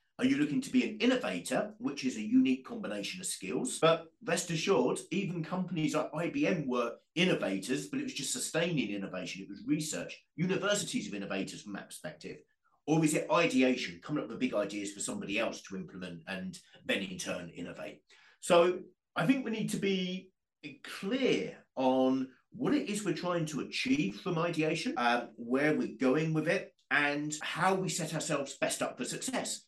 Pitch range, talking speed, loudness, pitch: 130-200 Hz, 180 wpm, -32 LUFS, 165 Hz